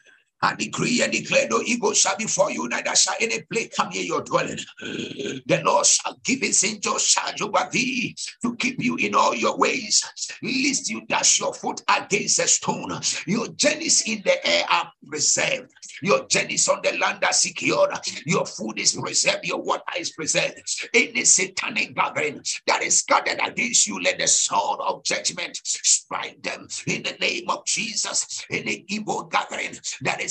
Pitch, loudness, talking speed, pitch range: 255 Hz, -21 LUFS, 180 wpm, 220-280 Hz